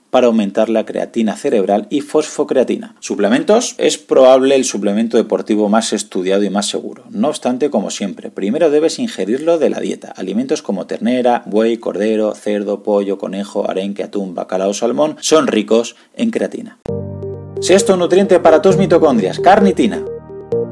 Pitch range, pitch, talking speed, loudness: 105-155 Hz, 115 Hz, 150 wpm, -15 LUFS